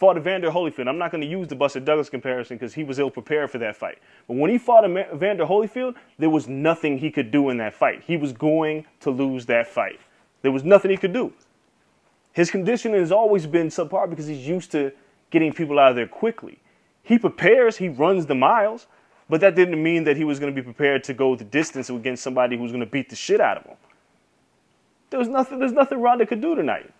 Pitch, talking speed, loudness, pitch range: 155 Hz, 240 wpm, -21 LUFS, 135-195 Hz